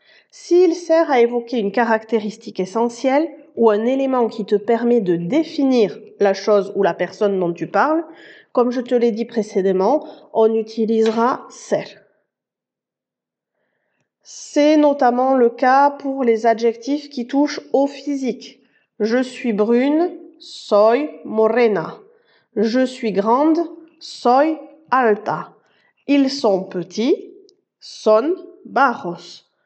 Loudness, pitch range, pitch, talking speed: -18 LUFS, 220-290 Hz, 245 Hz, 115 wpm